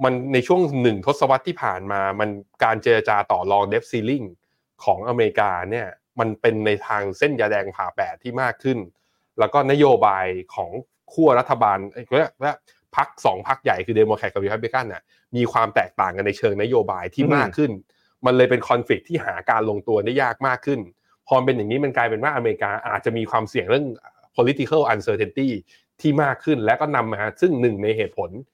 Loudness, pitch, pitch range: -21 LUFS, 125 Hz, 105-140 Hz